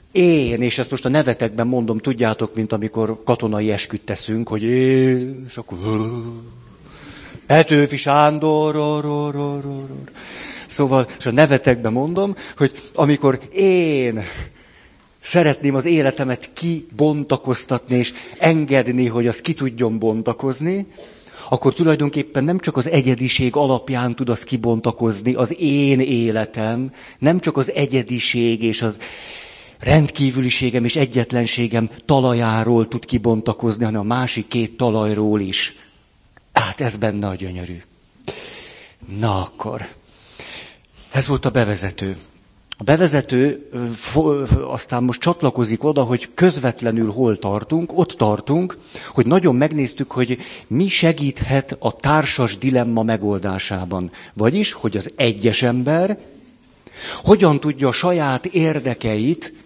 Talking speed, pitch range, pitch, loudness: 120 wpm, 115-145 Hz, 125 Hz, -18 LUFS